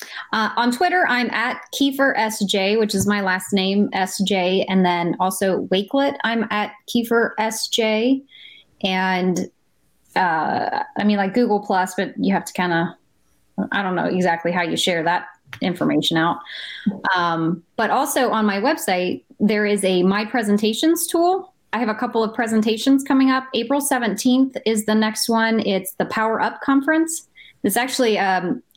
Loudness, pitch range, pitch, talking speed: -20 LUFS, 190-255 Hz, 215 Hz, 165 wpm